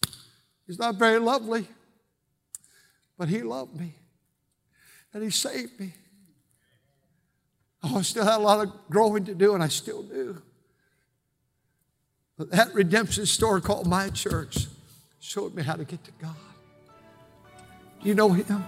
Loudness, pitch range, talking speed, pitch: -25 LUFS, 145-210 Hz, 140 wpm, 185 Hz